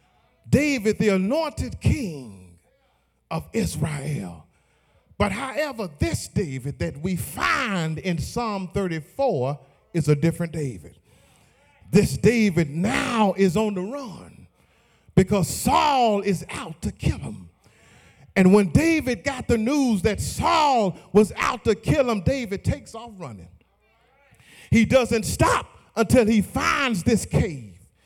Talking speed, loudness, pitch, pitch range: 125 wpm, -23 LUFS, 195 Hz, 150-230 Hz